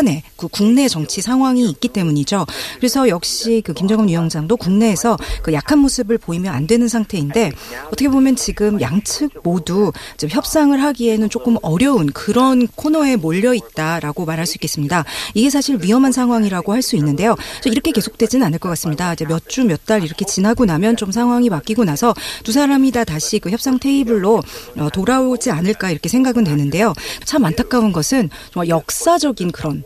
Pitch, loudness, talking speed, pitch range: 220 Hz, -16 LUFS, 385 characters per minute, 170-250 Hz